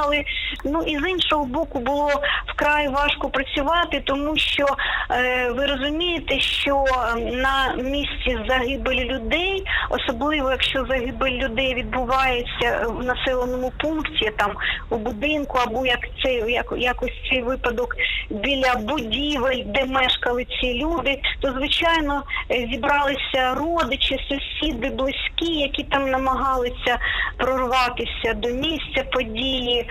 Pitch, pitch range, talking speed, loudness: 270 Hz, 255-295 Hz, 110 wpm, -22 LUFS